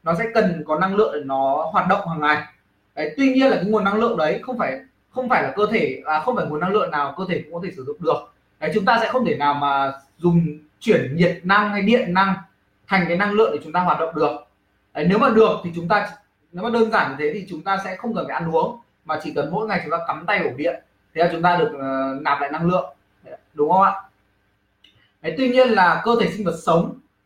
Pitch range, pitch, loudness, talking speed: 150-215 Hz, 175 Hz, -20 LUFS, 270 wpm